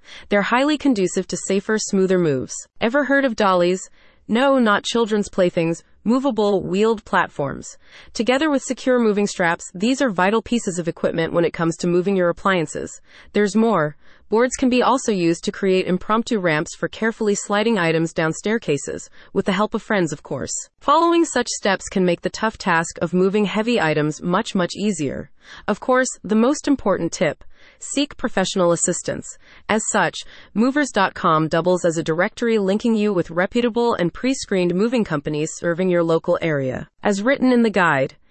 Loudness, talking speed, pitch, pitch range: -20 LUFS, 170 wpm, 200 Hz, 175-235 Hz